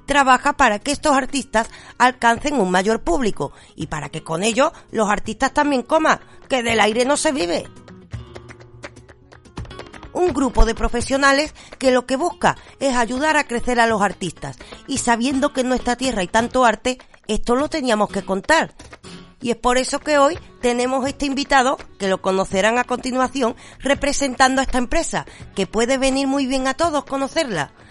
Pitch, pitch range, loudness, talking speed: 255 Hz, 220-275 Hz, -19 LUFS, 170 wpm